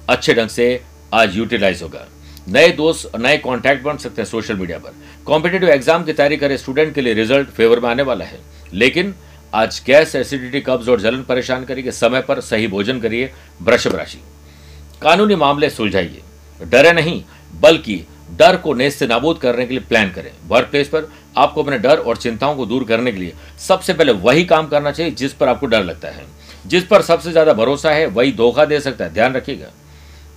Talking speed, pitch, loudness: 200 wpm, 125 Hz, -15 LUFS